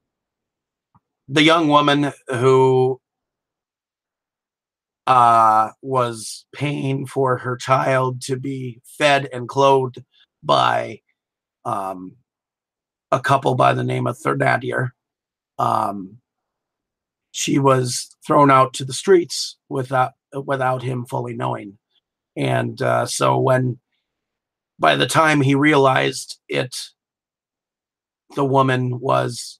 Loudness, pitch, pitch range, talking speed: -18 LUFS, 130 Hz, 120-135 Hz, 100 wpm